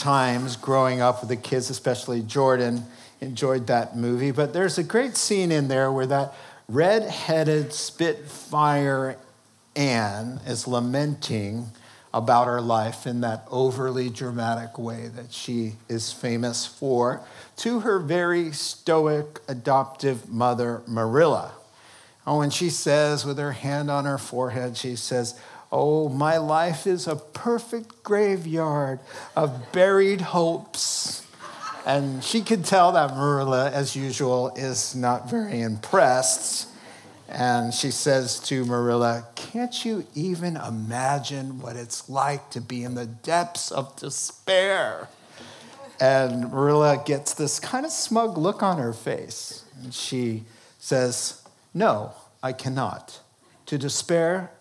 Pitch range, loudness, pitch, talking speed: 120-155 Hz, -24 LUFS, 135 Hz, 130 wpm